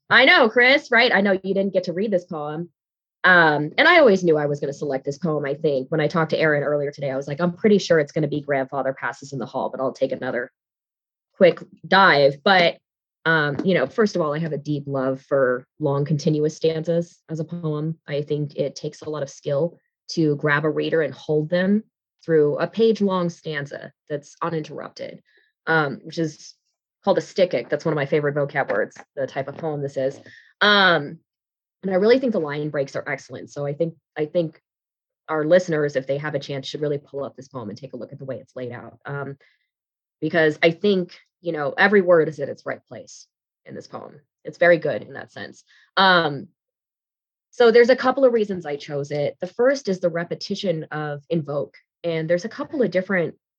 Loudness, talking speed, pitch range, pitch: -21 LUFS, 220 wpm, 145-180 Hz, 155 Hz